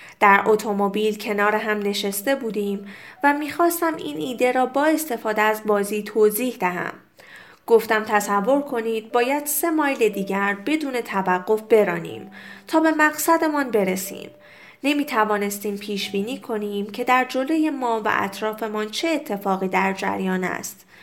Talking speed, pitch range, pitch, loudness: 135 wpm, 205-275 Hz, 215 Hz, -22 LUFS